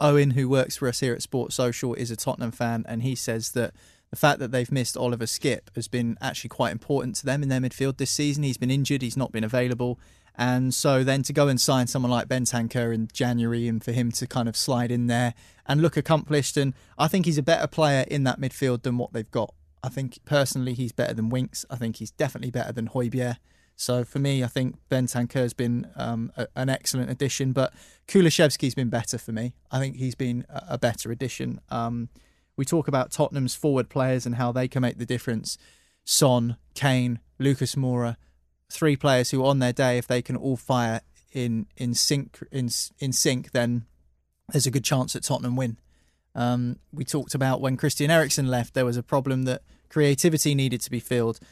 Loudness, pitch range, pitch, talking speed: -25 LUFS, 120-135 Hz, 125 Hz, 215 wpm